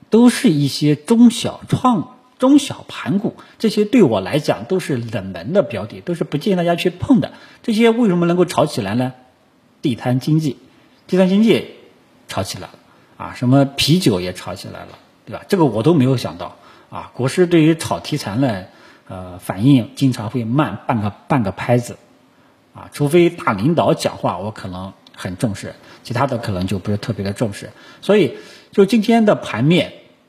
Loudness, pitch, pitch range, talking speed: -17 LUFS, 140 Hz, 115-180 Hz, 265 characters per minute